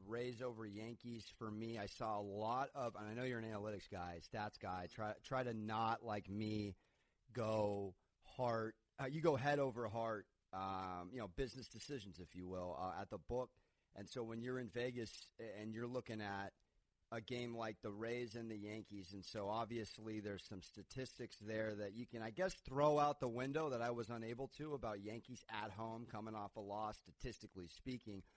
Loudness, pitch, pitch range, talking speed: -46 LUFS, 110 Hz, 100-120 Hz, 200 wpm